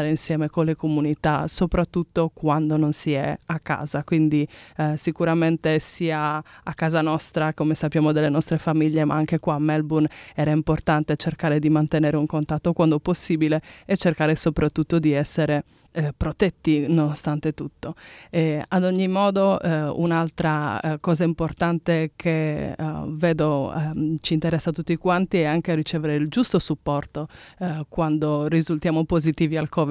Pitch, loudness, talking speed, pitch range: 155 Hz, -23 LUFS, 155 wpm, 155-165 Hz